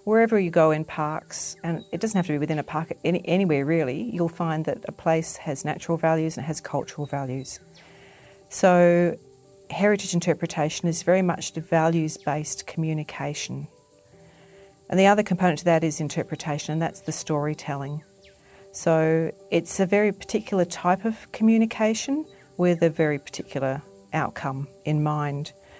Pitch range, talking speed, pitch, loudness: 150-185 Hz, 155 wpm, 165 Hz, -24 LUFS